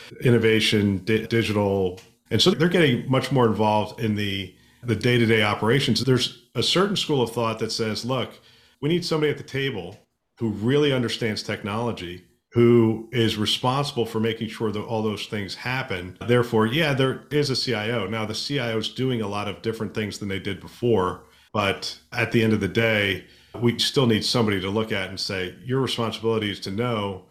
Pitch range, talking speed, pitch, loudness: 105-120 Hz, 190 wpm, 115 Hz, -23 LUFS